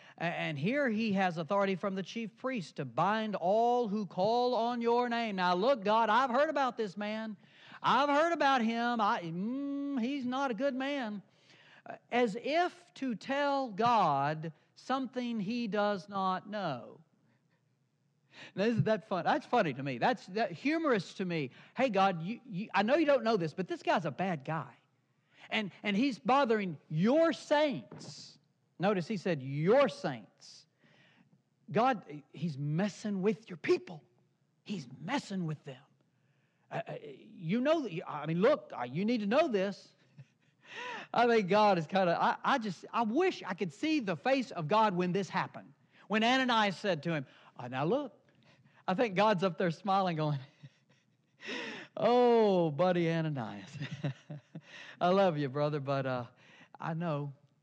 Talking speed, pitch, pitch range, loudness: 165 wpm, 200 Hz, 160-240 Hz, -32 LUFS